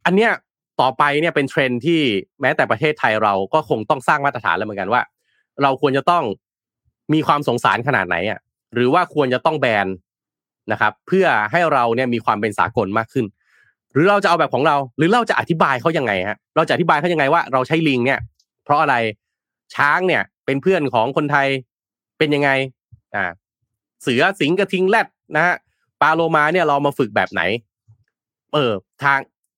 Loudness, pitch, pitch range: -18 LUFS, 140 Hz, 120-160 Hz